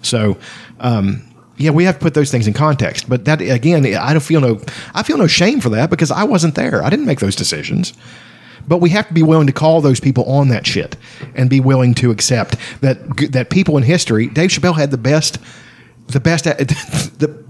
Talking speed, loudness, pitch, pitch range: 225 wpm, -14 LUFS, 140 Hz, 120-155 Hz